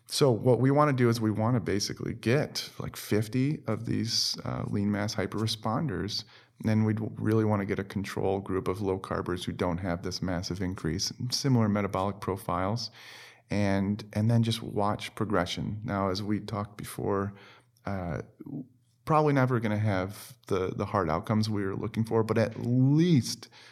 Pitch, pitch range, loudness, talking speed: 110 Hz, 100-120 Hz, -29 LUFS, 175 wpm